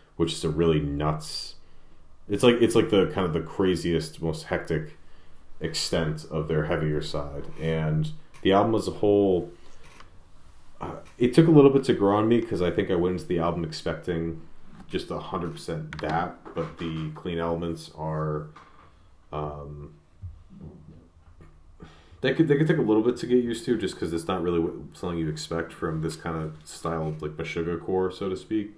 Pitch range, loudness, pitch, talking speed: 80-95 Hz, -26 LUFS, 85 Hz, 190 wpm